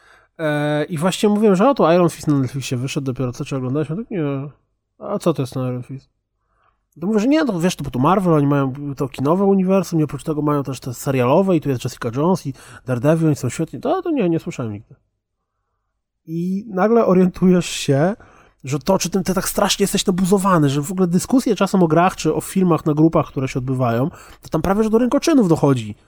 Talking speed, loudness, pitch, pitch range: 230 wpm, -18 LUFS, 155 Hz, 135-190 Hz